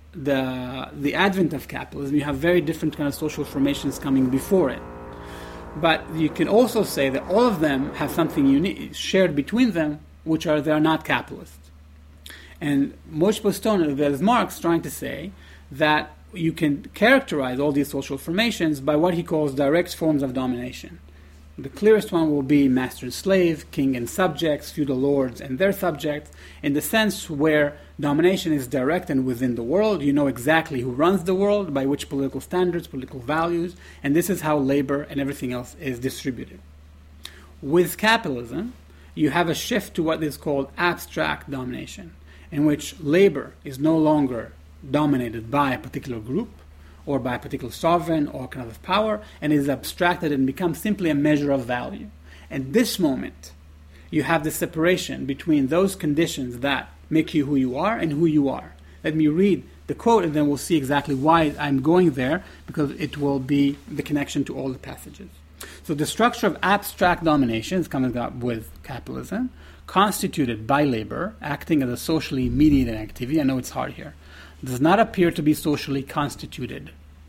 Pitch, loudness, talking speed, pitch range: 145 Hz, -23 LUFS, 180 wpm, 130-165 Hz